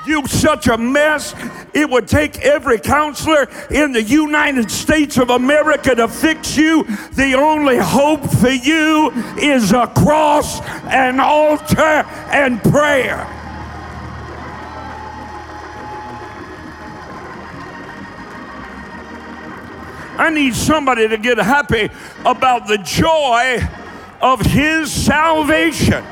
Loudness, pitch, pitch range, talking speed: -14 LUFS, 290 Hz, 245-305 Hz, 95 wpm